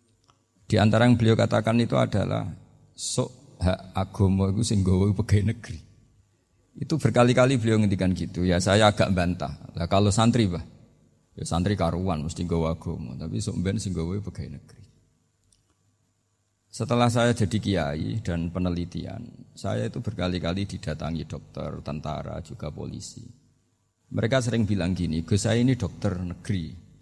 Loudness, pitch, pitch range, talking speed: -25 LUFS, 100 Hz, 90-115 Hz, 140 wpm